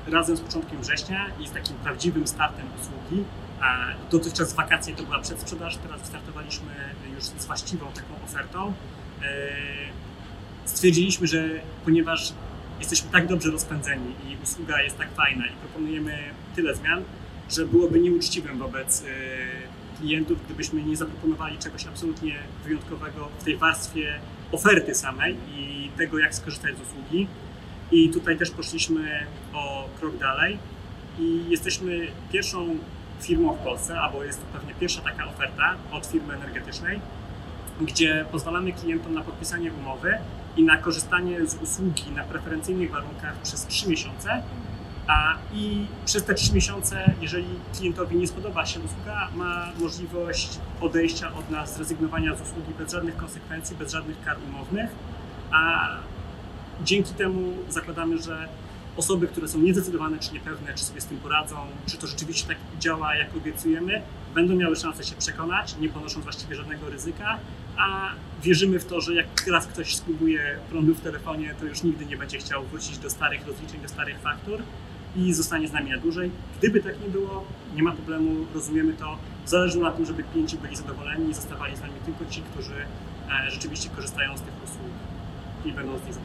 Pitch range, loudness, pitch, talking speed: 140-170 Hz, -26 LUFS, 160 Hz, 155 wpm